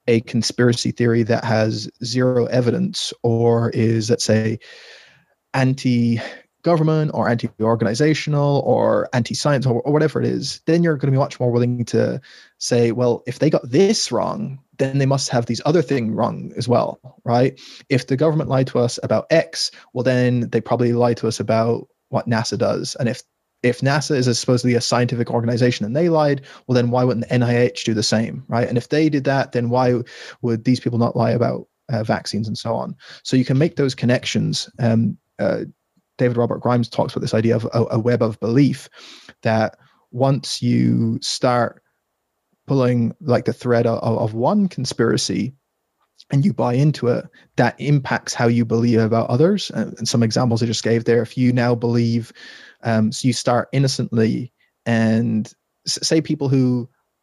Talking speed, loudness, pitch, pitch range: 185 wpm, -19 LUFS, 120 Hz, 115-135 Hz